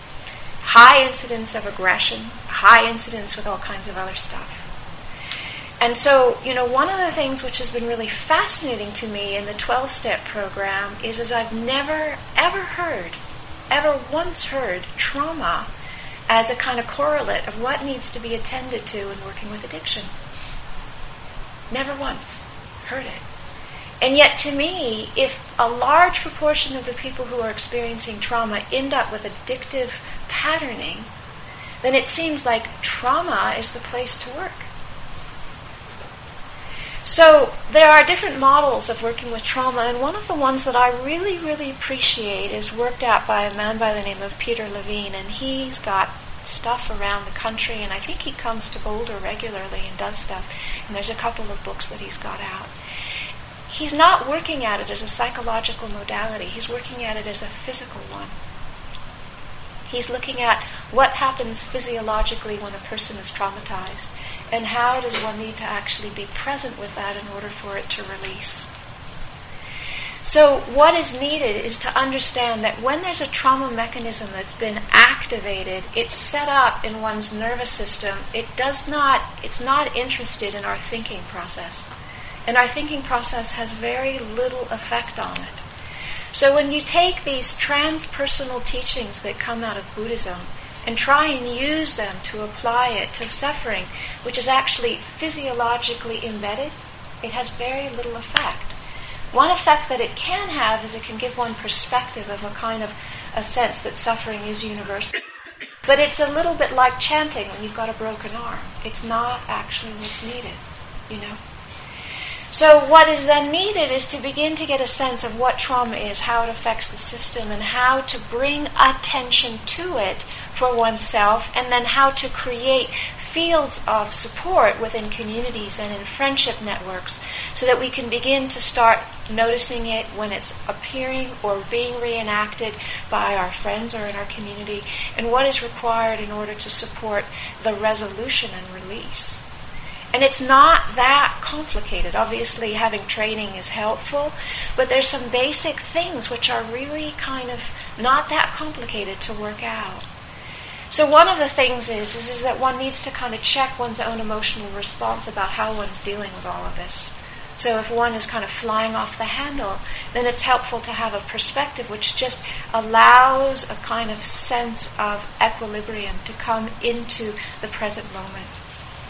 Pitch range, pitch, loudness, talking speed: 220-270 Hz, 245 Hz, -19 LUFS, 170 wpm